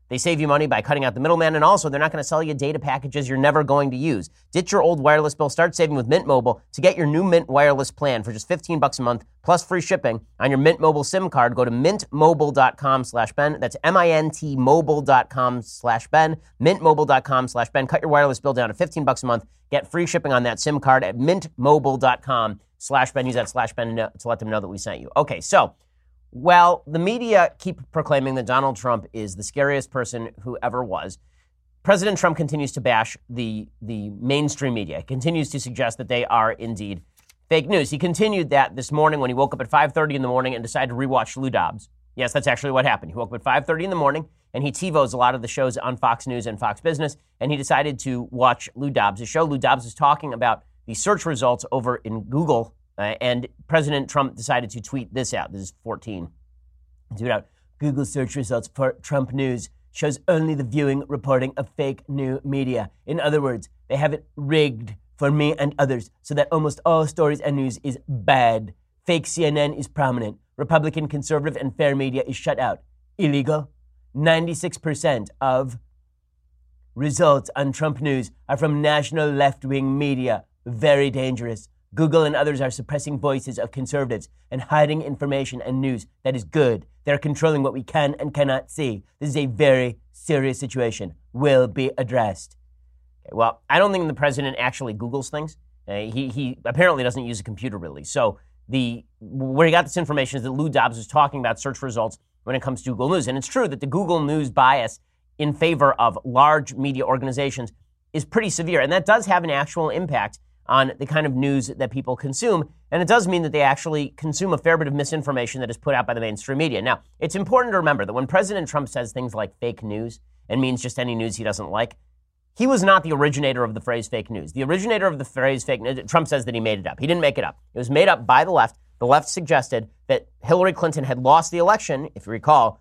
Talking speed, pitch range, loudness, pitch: 210 wpm, 120-150 Hz, -21 LUFS, 135 Hz